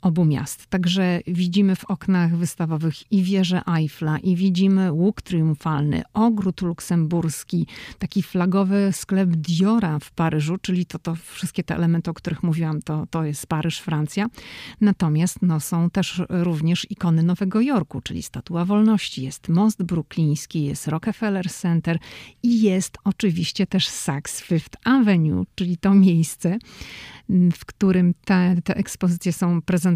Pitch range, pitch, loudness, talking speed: 165-190 Hz, 175 Hz, -22 LUFS, 140 wpm